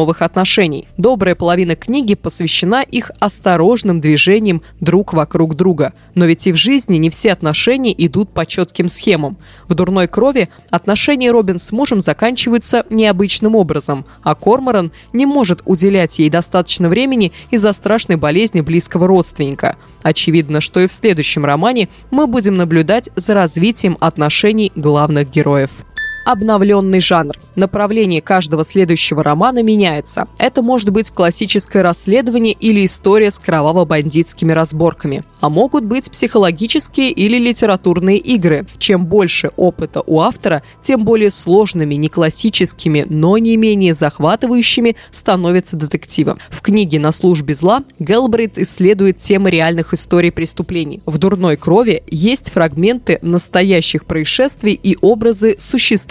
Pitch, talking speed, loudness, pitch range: 185 Hz, 130 wpm, -12 LUFS, 165-220 Hz